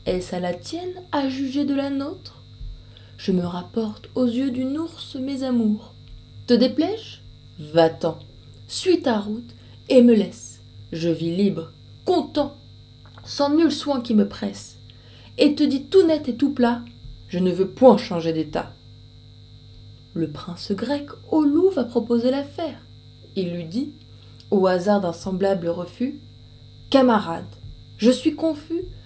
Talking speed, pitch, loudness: 145 wpm, 205 Hz, -22 LUFS